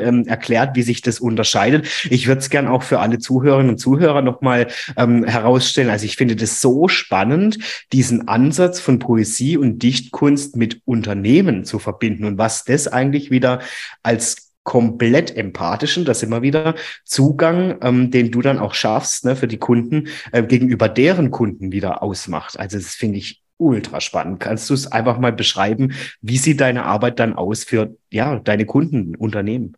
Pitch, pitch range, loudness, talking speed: 125 Hz, 115-135 Hz, -17 LUFS, 170 wpm